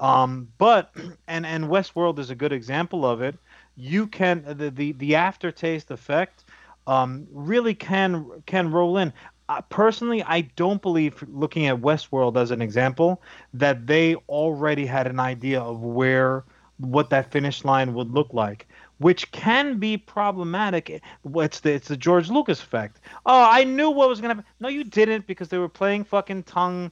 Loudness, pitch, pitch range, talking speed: -23 LUFS, 160 Hz, 135-190 Hz, 175 wpm